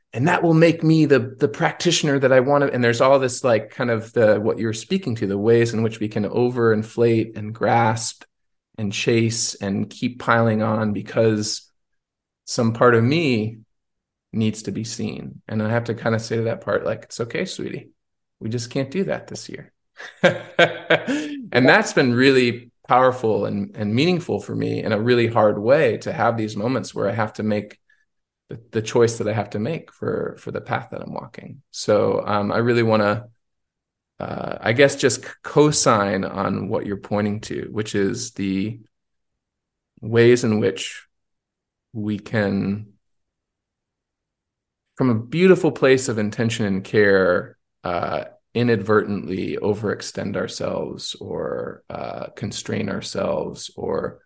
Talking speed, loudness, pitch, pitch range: 165 wpm, -20 LUFS, 115 Hz, 105-125 Hz